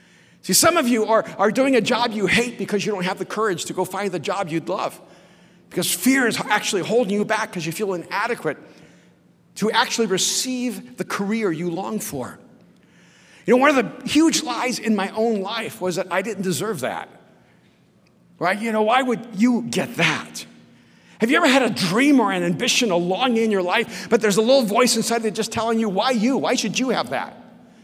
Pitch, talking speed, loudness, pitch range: 215 Hz, 215 wpm, -20 LUFS, 185-235 Hz